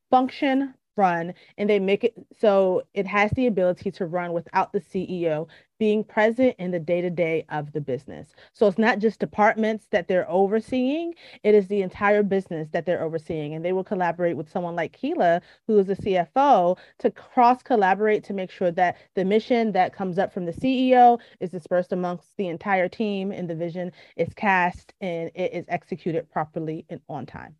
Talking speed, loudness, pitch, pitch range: 190 wpm, -23 LUFS, 190 Hz, 175-215 Hz